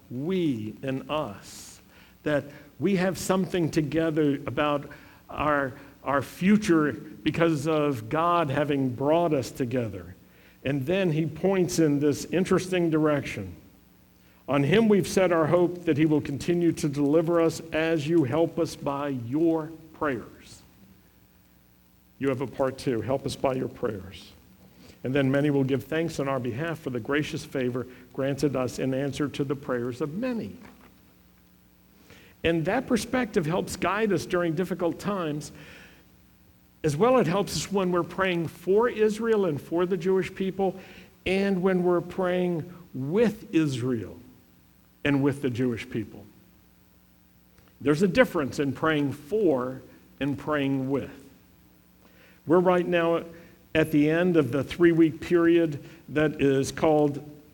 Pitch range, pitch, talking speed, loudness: 135-175 Hz, 155 Hz, 145 wpm, -26 LUFS